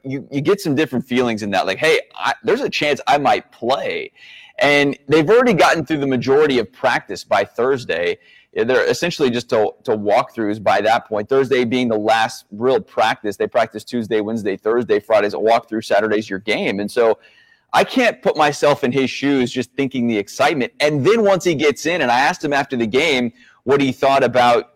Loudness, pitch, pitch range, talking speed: -17 LUFS, 135 Hz, 115-160 Hz, 210 wpm